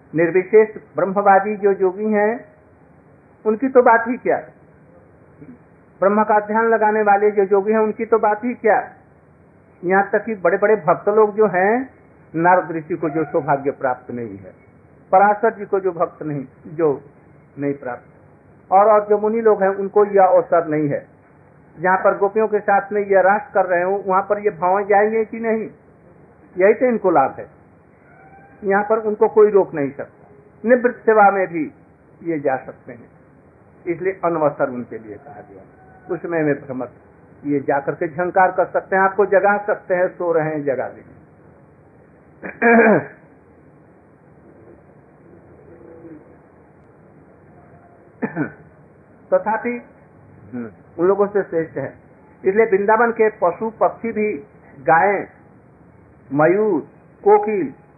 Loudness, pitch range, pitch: -18 LUFS, 165-215 Hz, 195 Hz